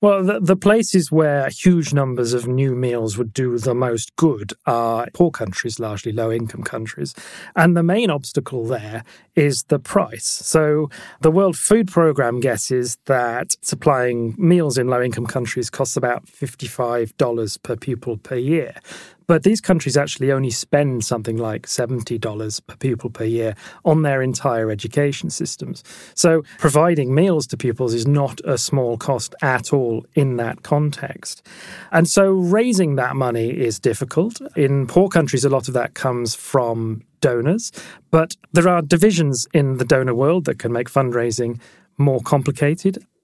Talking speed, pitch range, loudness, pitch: 160 wpm, 120-160 Hz, -19 LUFS, 135 Hz